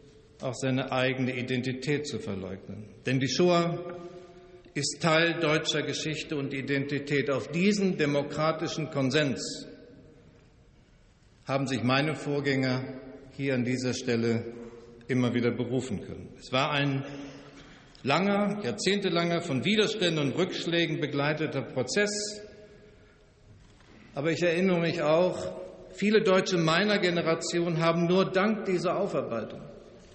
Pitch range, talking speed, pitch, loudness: 130-175 Hz, 110 wpm, 145 Hz, -28 LUFS